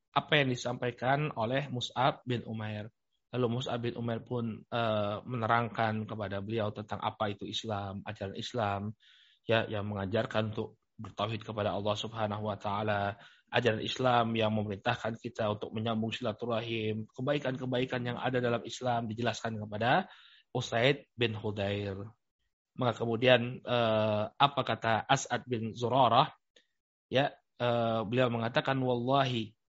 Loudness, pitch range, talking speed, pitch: -32 LUFS, 105-120 Hz, 120 wpm, 115 Hz